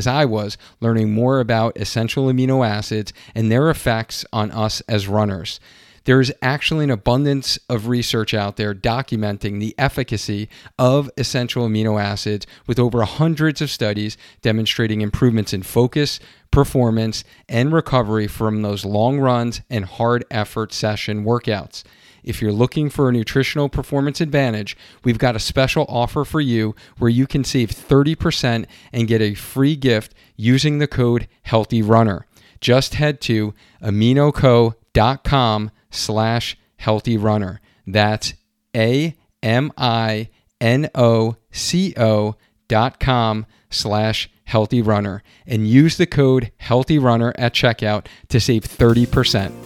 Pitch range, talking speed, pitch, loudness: 110-130 Hz, 125 wpm, 115 Hz, -18 LUFS